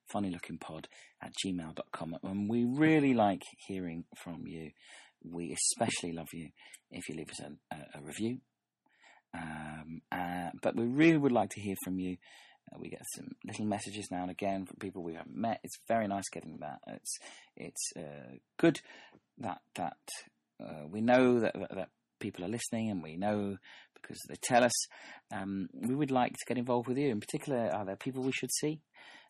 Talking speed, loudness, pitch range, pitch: 190 wpm, -34 LUFS, 85-120 Hz, 100 Hz